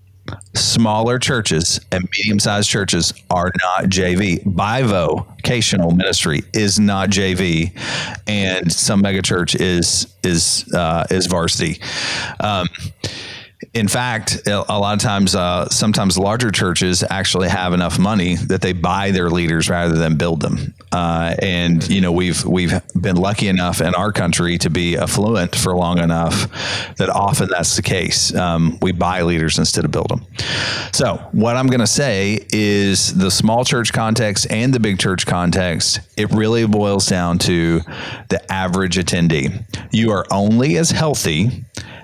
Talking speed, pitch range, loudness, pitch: 150 wpm, 90-110 Hz, -16 LUFS, 95 Hz